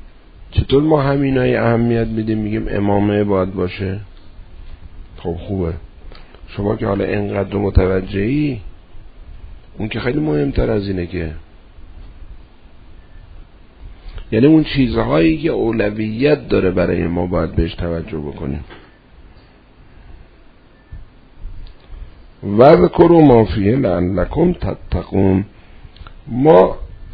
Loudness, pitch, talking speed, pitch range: -16 LUFS, 95 Hz, 95 wpm, 85-115 Hz